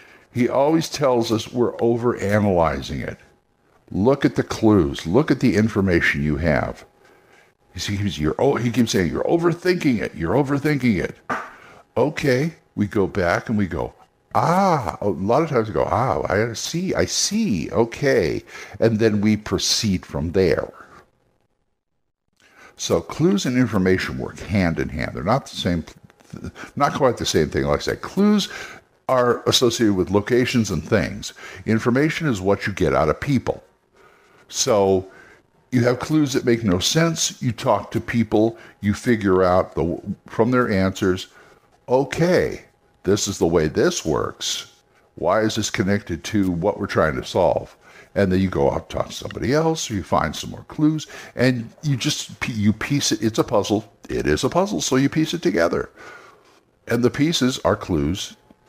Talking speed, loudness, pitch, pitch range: 165 wpm, -21 LUFS, 115 Hz, 100-135 Hz